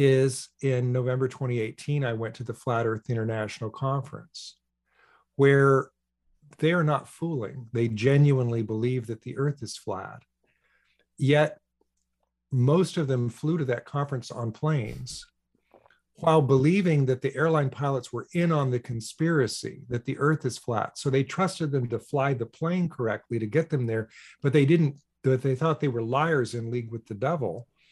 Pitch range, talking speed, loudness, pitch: 120-150 Hz, 165 wpm, -26 LUFS, 135 Hz